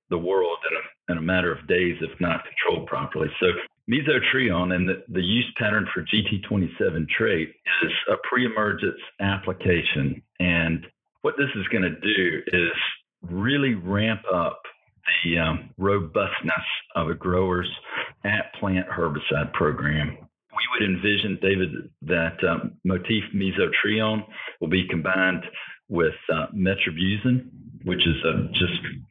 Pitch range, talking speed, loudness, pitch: 90-105 Hz, 140 wpm, -24 LUFS, 95 Hz